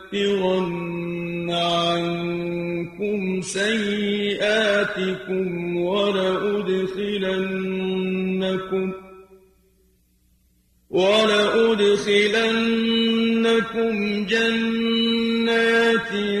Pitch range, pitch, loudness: 185-215 Hz, 195 Hz, -21 LUFS